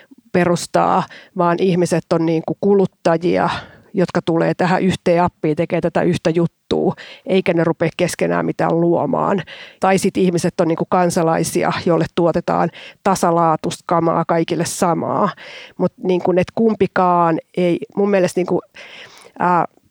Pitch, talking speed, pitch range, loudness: 175 Hz, 125 wpm, 170-185 Hz, -17 LUFS